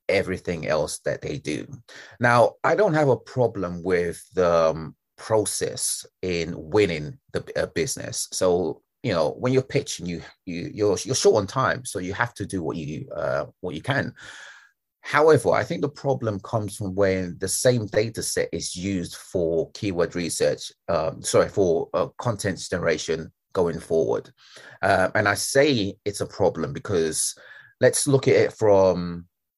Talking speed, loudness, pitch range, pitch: 165 wpm, -24 LUFS, 85-120 Hz, 95 Hz